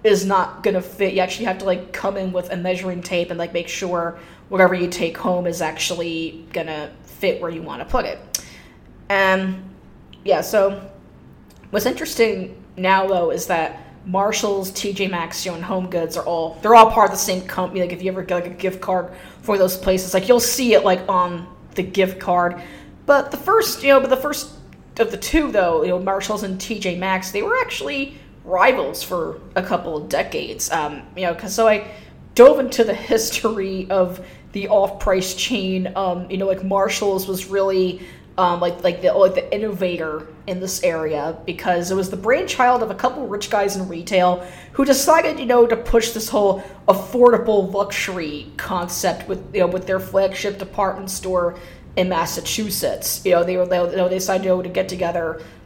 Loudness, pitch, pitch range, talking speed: -19 LUFS, 190 Hz, 180-210 Hz, 200 wpm